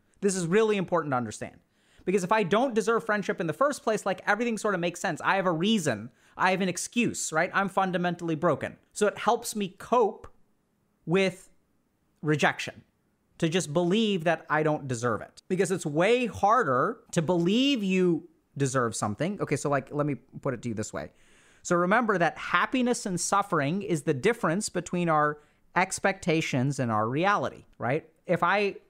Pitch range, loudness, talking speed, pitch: 150-200 Hz, -27 LUFS, 180 wpm, 175 Hz